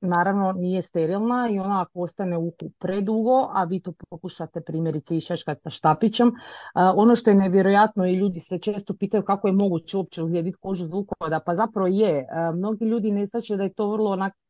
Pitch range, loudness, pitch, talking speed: 175-210 Hz, -23 LUFS, 190 Hz, 185 wpm